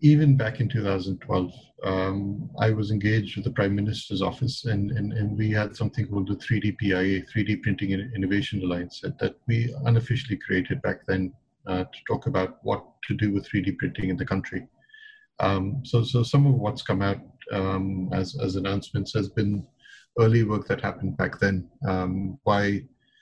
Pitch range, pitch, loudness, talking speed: 95-115 Hz, 105 Hz, -26 LUFS, 180 wpm